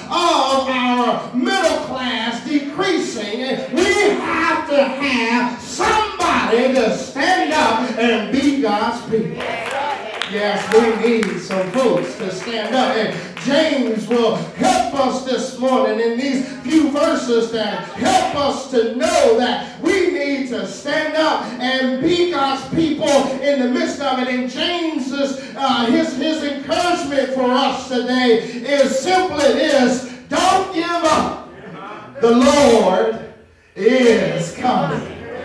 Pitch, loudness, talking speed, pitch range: 265 Hz, -17 LUFS, 125 wpm, 235-305 Hz